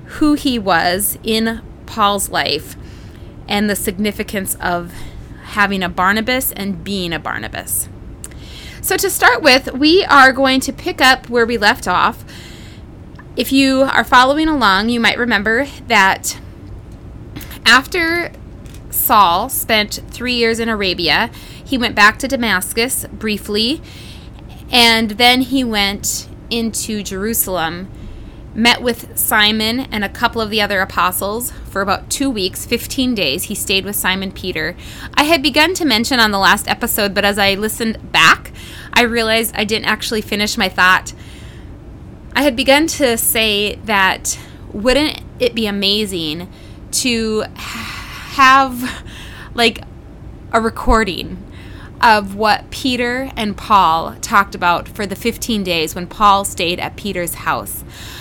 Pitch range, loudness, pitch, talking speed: 195-250 Hz, -15 LUFS, 220 Hz, 140 wpm